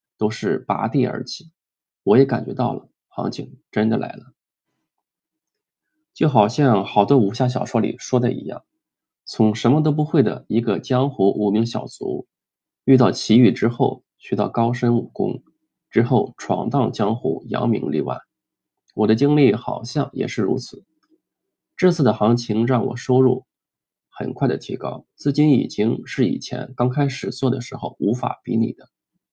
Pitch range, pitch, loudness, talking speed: 110-140 Hz, 125 Hz, -20 LUFS, 230 characters per minute